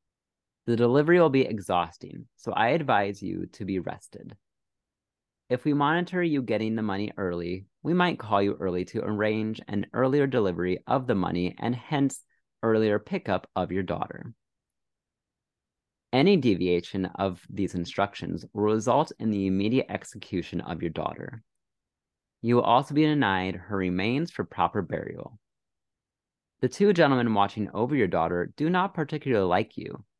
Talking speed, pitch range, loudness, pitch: 150 wpm, 95-135 Hz, -27 LUFS, 110 Hz